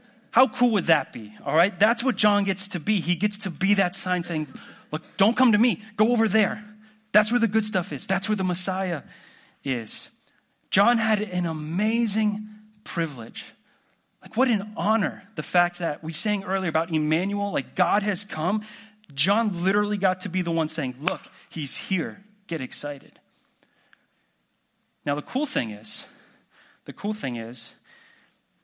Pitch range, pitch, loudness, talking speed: 165-215 Hz, 200 Hz, -25 LUFS, 170 wpm